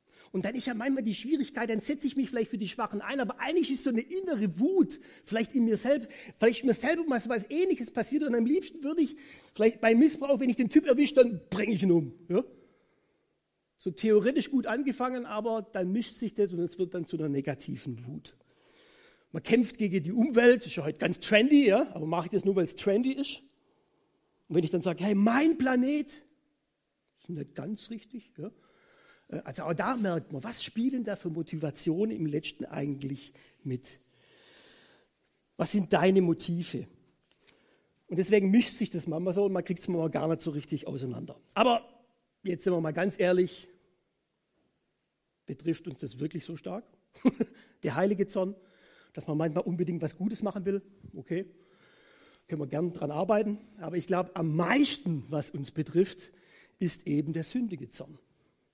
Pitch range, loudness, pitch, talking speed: 170-255 Hz, -29 LUFS, 205 Hz, 190 wpm